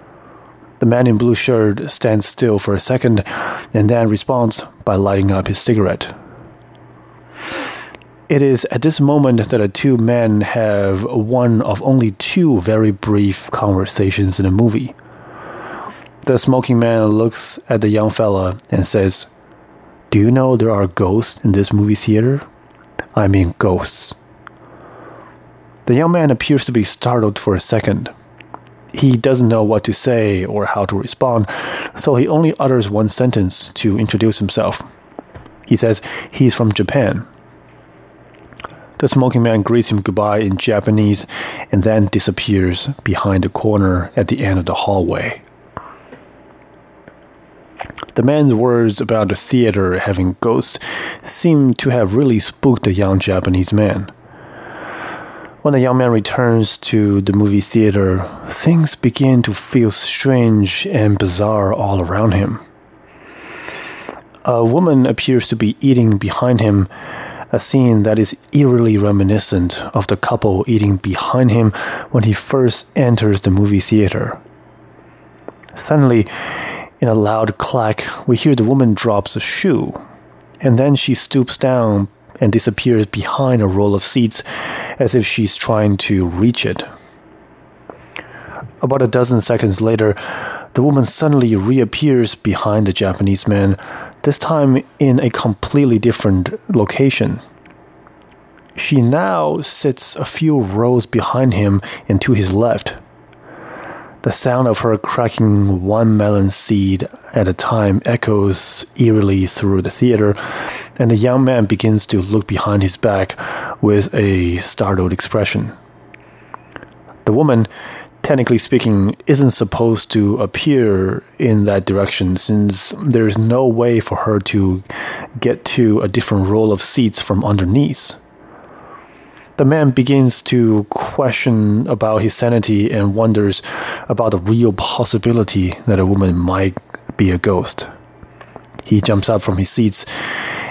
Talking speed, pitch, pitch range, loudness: 140 wpm, 110 Hz, 100-125 Hz, -15 LUFS